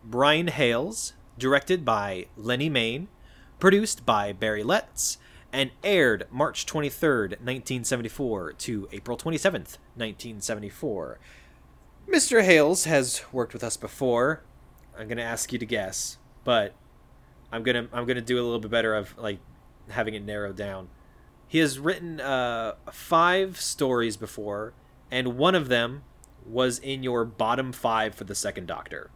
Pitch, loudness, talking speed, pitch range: 120 Hz, -26 LUFS, 140 wpm, 105-140 Hz